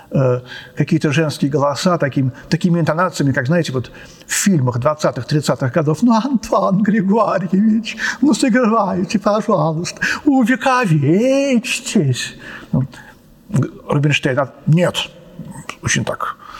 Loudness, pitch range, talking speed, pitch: -16 LUFS, 150-220 Hz, 90 wpm, 175 Hz